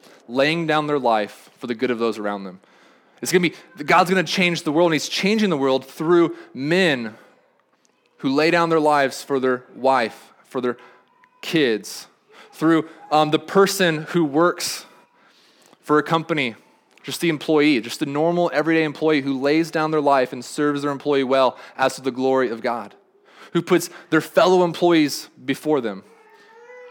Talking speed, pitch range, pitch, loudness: 170 wpm, 135-170 Hz, 155 Hz, -20 LUFS